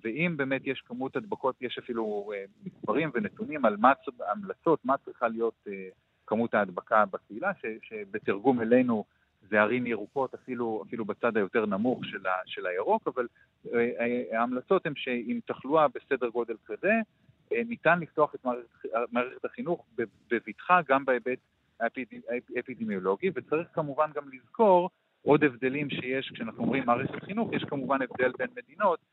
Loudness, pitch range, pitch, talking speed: -29 LUFS, 120-160 Hz, 130 Hz, 140 wpm